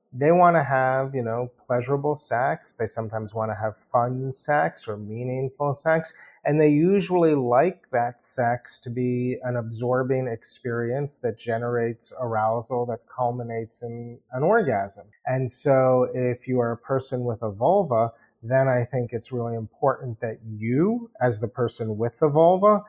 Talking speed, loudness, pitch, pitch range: 160 wpm, -24 LUFS, 125 Hz, 115-135 Hz